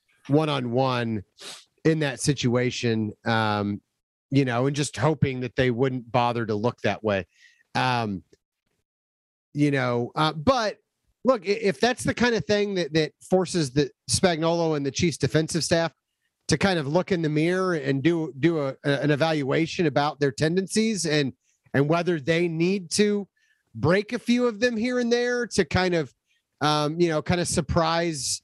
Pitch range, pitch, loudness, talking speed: 130-180 Hz, 155 Hz, -24 LUFS, 170 wpm